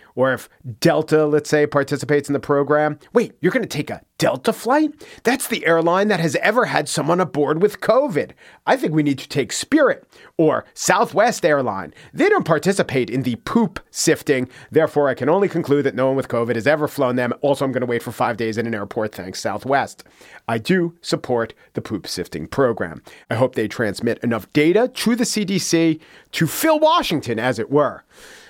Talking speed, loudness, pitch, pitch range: 200 wpm, -19 LUFS, 150 Hz, 125-170 Hz